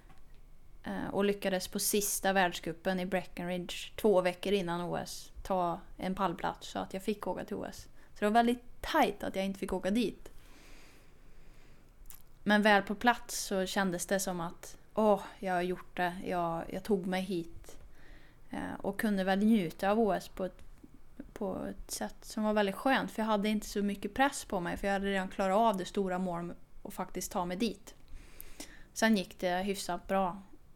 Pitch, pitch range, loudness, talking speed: 195 Hz, 180-210 Hz, -33 LUFS, 185 wpm